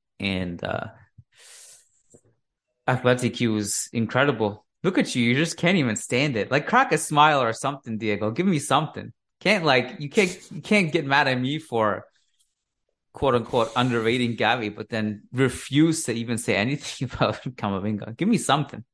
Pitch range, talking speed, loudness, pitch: 110-150 Hz, 165 wpm, -23 LUFS, 125 Hz